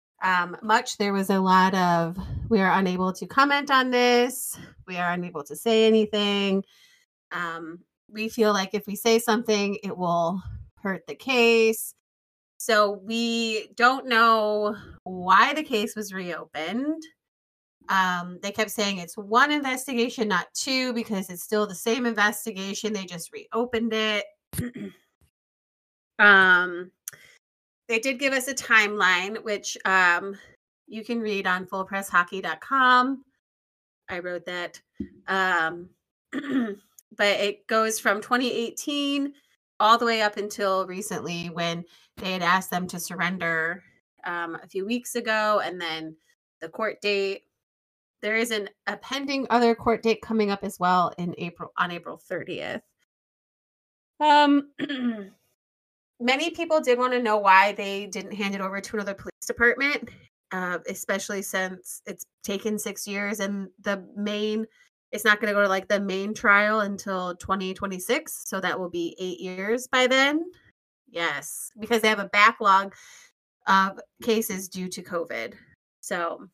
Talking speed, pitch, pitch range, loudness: 145 wpm, 205 Hz, 185-230 Hz, -24 LUFS